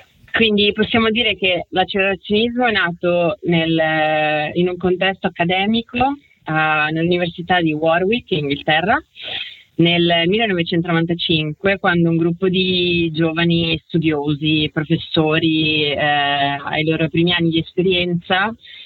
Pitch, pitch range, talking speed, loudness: 170 Hz, 160-190 Hz, 110 wpm, -17 LUFS